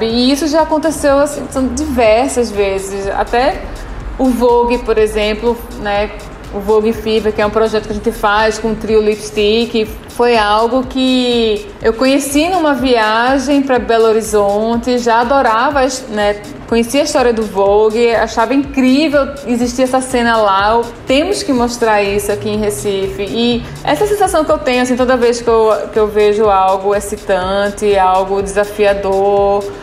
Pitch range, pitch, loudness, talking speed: 210-255 Hz, 225 Hz, -13 LUFS, 160 wpm